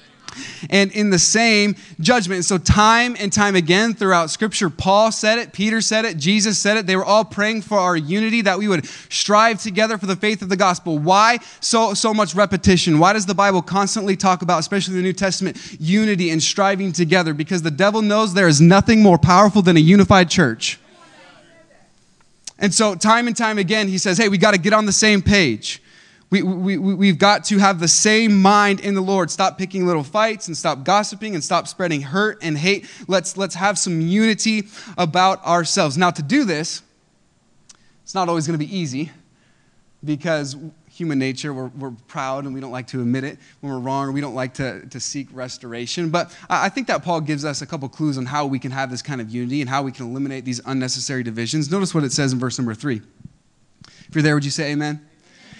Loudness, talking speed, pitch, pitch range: -17 LUFS, 215 wpm, 185 Hz, 150-205 Hz